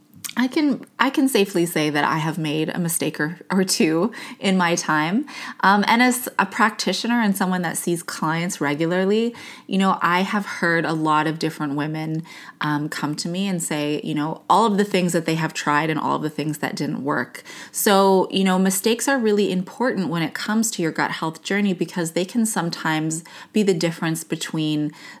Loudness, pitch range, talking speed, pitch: -21 LUFS, 160-205 Hz, 205 wpm, 175 Hz